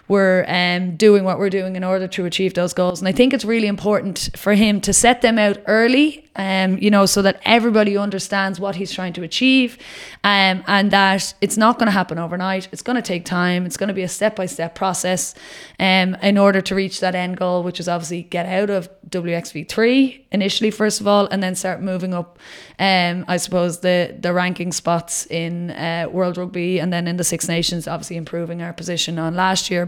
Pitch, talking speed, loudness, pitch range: 185 Hz, 220 wpm, -18 LUFS, 175-200 Hz